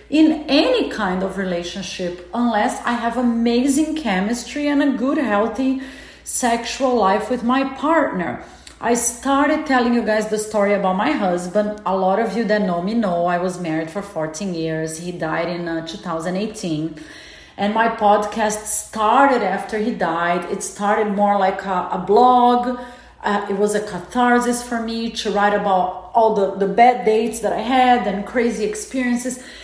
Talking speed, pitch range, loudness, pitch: 170 wpm, 190-245 Hz, -19 LUFS, 215 Hz